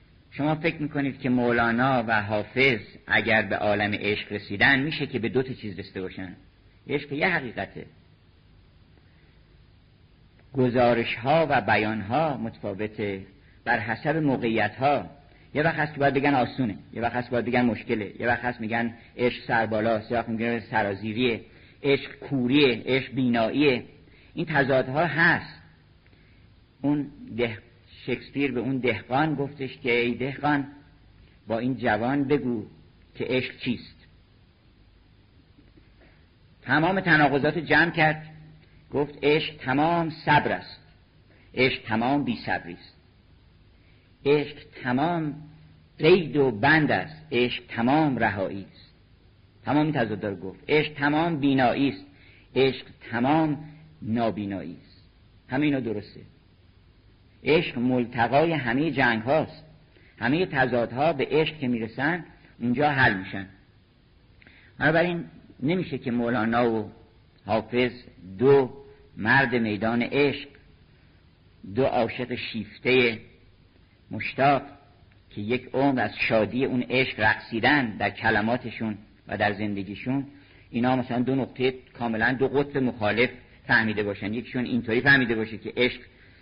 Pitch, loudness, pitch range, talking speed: 120 Hz, -25 LUFS, 105-140 Hz, 120 wpm